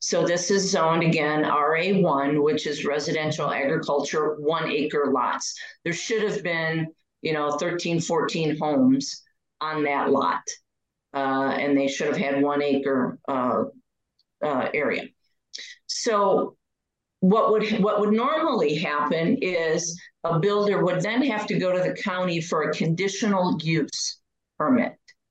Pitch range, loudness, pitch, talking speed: 150-205 Hz, -24 LUFS, 165 Hz, 140 wpm